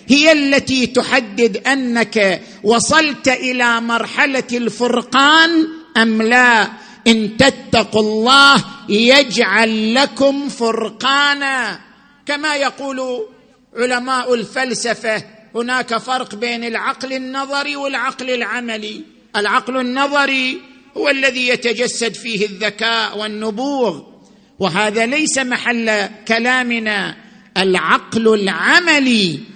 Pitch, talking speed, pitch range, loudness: 245 Hz, 85 wpm, 220-265 Hz, -15 LUFS